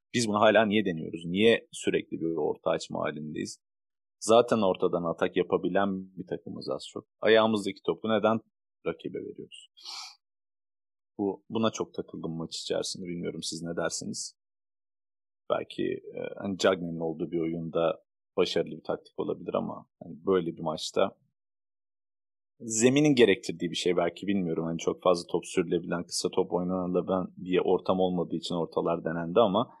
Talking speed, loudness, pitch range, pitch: 145 wpm, -29 LUFS, 85-100 Hz, 95 Hz